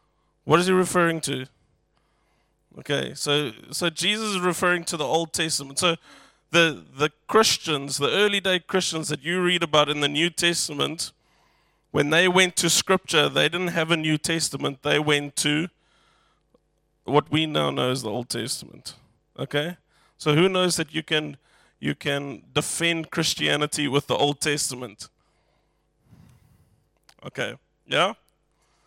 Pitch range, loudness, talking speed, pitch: 145-175 Hz, -23 LUFS, 145 wpm, 155 Hz